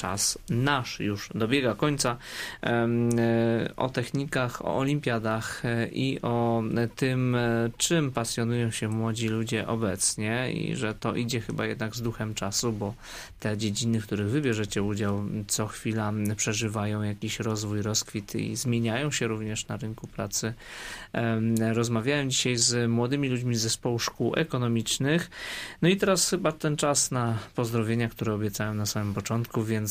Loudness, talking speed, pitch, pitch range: -28 LUFS, 140 wpm, 115 Hz, 110-125 Hz